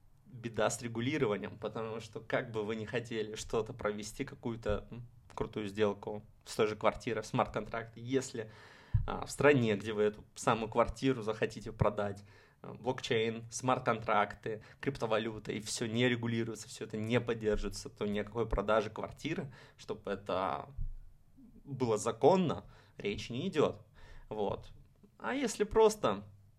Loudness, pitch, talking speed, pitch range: -35 LUFS, 115 Hz, 125 wpm, 105-125 Hz